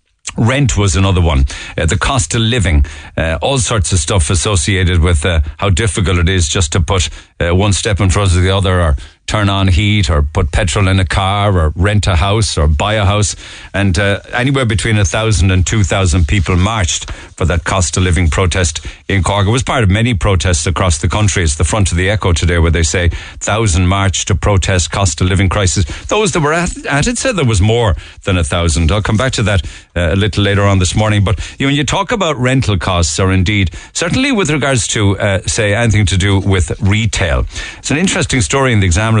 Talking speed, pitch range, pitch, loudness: 230 wpm, 90-105 Hz, 95 Hz, -13 LUFS